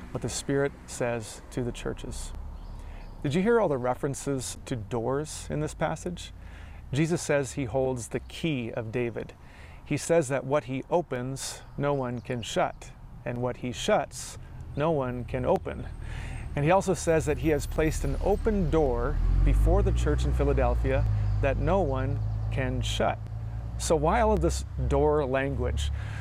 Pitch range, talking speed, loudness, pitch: 110-140 Hz, 165 wpm, -28 LUFS, 125 Hz